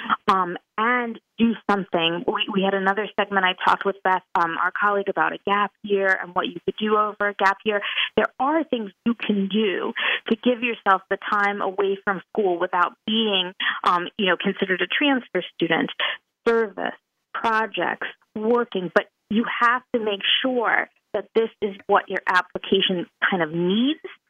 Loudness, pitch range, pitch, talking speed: -22 LUFS, 190-225 Hz, 200 Hz, 175 wpm